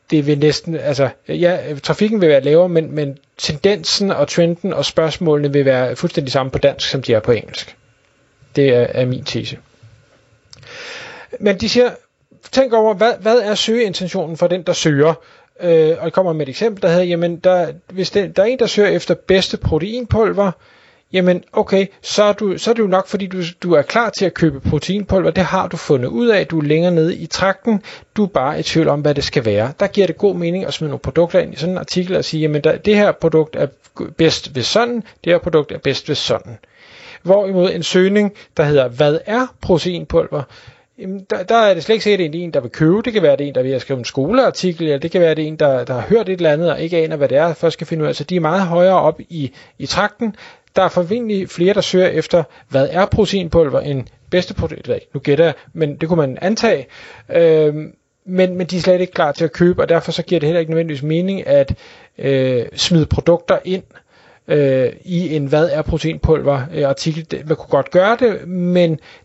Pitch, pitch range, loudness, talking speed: 170 Hz, 150-195 Hz, -16 LUFS, 235 wpm